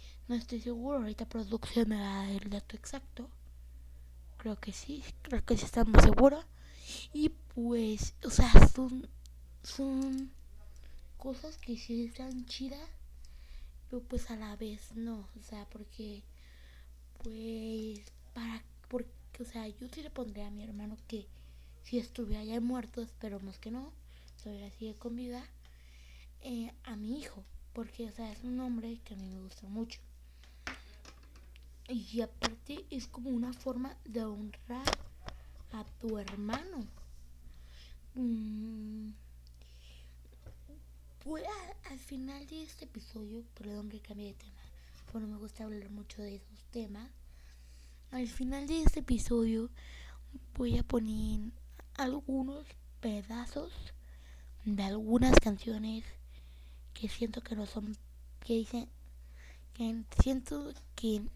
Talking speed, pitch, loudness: 130 wpm, 215 Hz, -36 LUFS